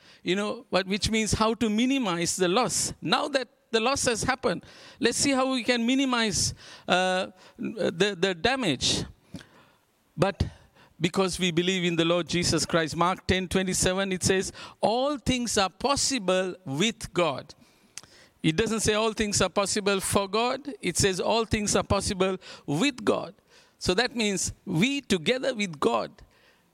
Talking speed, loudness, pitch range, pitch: 155 wpm, -26 LUFS, 185-250 Hz, 205 Hz